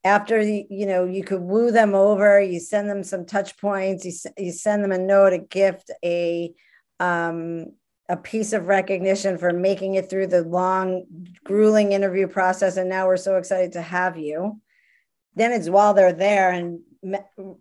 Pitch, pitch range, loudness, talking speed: 195 Hz, 180-200 Hz, -21 LUFS, 180 wpm